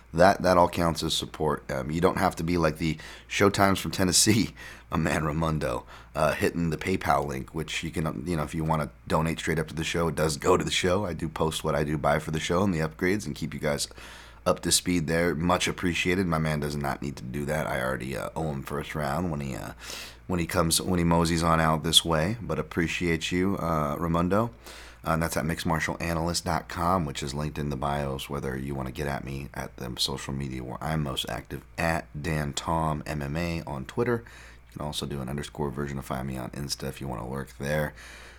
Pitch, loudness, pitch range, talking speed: 80 Hz, -27 LUFS, 70-85 Hz, 240 wpm